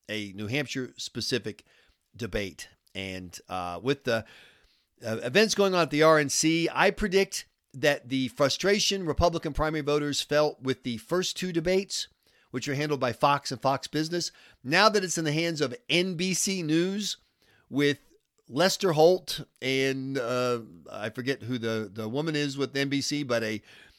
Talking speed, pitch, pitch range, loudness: 160 wpm, 145 Hz, 125-170 Hz, -27 LUFS